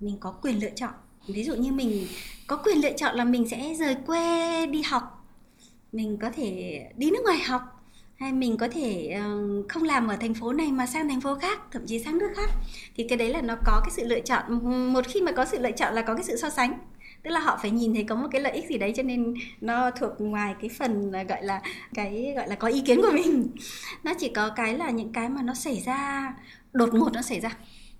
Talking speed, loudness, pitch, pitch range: 250 wpm, -27 LUFS, 245 Hz, 225-275 Hz